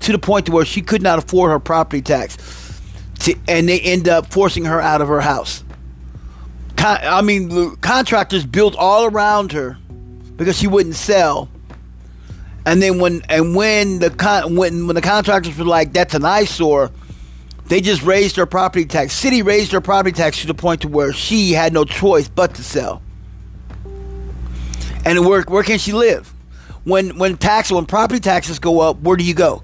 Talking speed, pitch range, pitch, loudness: 190 wpm, 145-195 Hz, 170 Hz, -15 LUFS